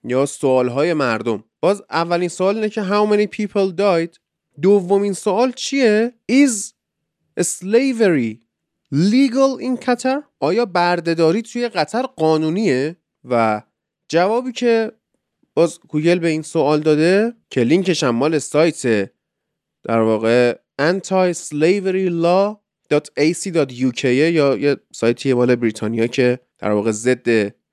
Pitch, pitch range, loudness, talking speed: 165 Hz, 130-205 Hz, -18 LUFS, 115 wpm